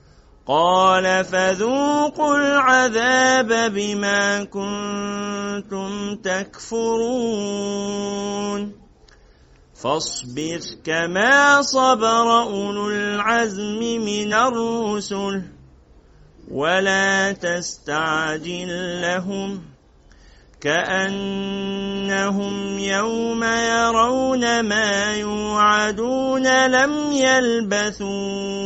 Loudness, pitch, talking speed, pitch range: -20 LUFS, 205 Hz, 50 wpm, 195-230 Hz